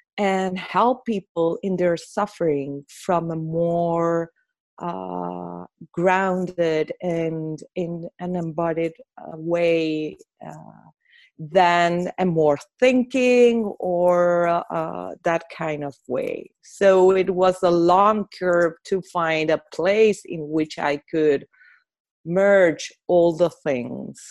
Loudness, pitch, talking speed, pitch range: -21 LUFS, 175 Hz, 110 wpm, 165-190 Hz